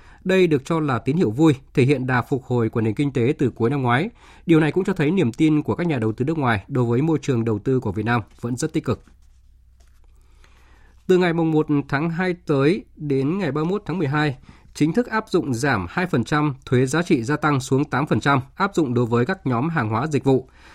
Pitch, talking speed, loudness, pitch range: 140 Hz, 235 wpm, -21 LUFS, 120-160 Hz